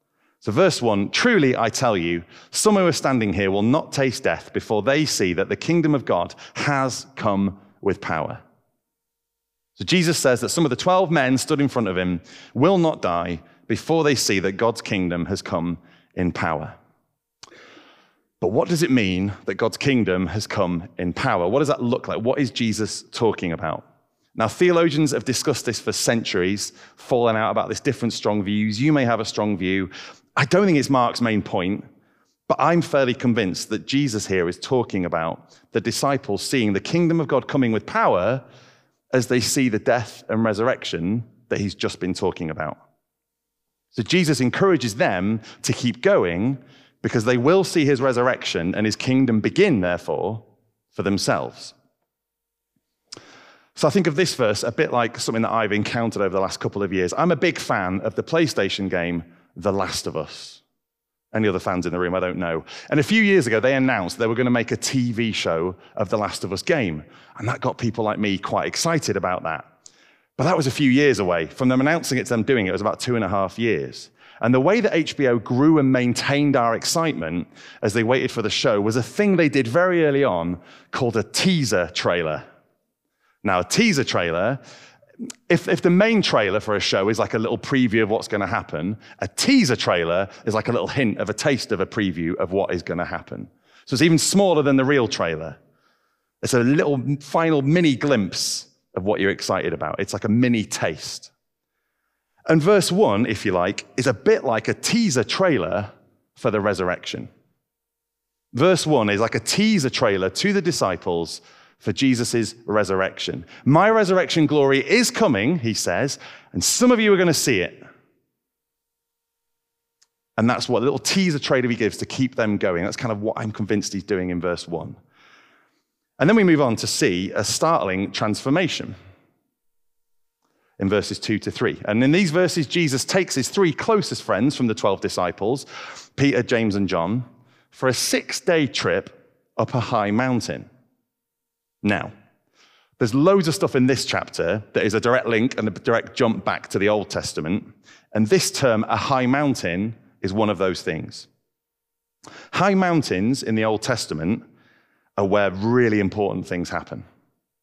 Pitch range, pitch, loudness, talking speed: 100-145 Hz, 120 Hz, -21 LUFS, 190 wpm